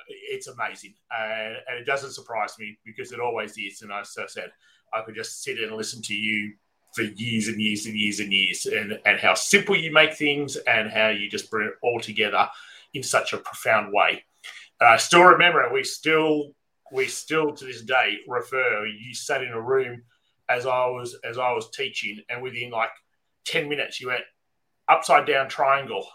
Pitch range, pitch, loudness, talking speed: 110-155 Hz, 125 Hz, -23 LUFS, 195 wpm